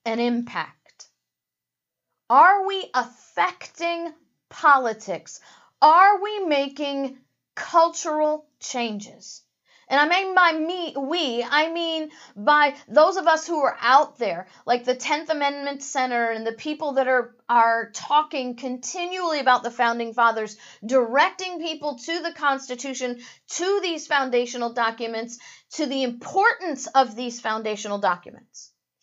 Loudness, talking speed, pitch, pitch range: -22 LUFS, 125 wpm, 275 Hz, 240-315 Hz